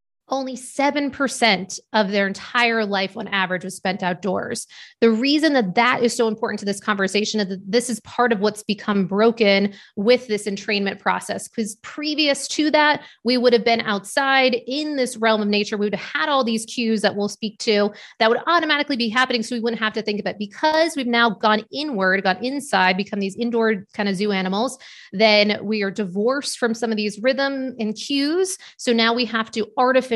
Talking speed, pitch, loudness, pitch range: 205 wpm, 225 Hz, -20 LUFS, 205-255 Hz